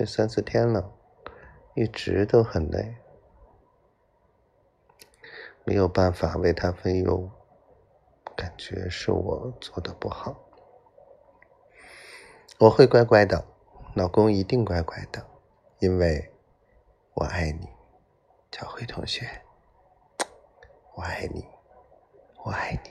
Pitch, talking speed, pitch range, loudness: 100 Hz, 135 characters per minute, 90-115 Hz, -25 LUFS